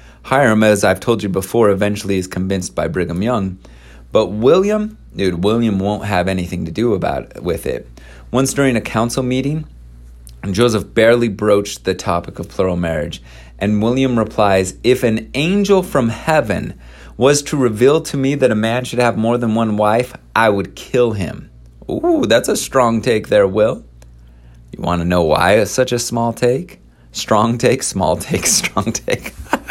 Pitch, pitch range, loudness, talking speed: 110 Hz, 90-125 Hz, -16 LUFS, 175 wpm